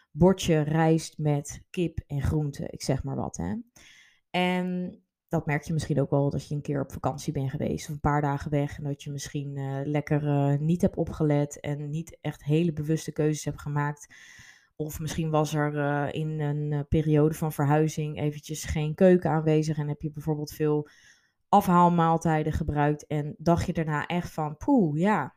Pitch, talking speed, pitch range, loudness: 150 Hz, 185 wpm, 145-160 Hz, -27 LUFS